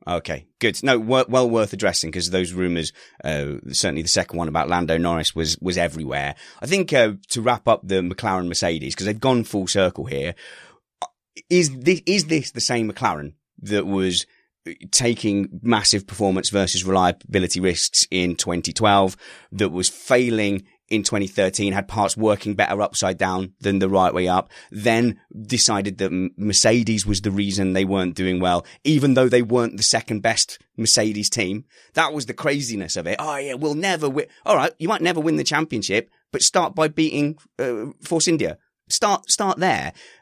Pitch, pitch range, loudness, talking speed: 100 Hz, 90-120 Hz, -20 LUFS, 175 wpm